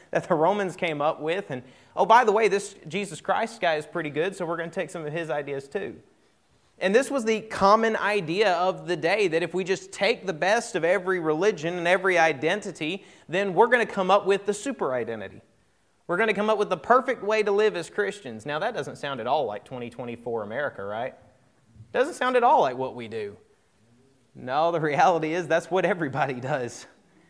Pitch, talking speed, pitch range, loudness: 175 Hz, 210 wpm, 150-200 Hz, -25 LUFS